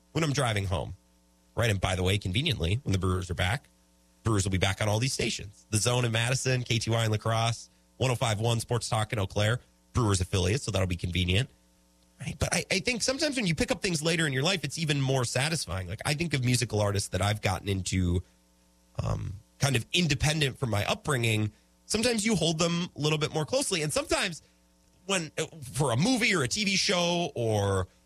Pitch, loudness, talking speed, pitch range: 115 Hz, -28 LUFS, 210 wpm, 95-155 Hz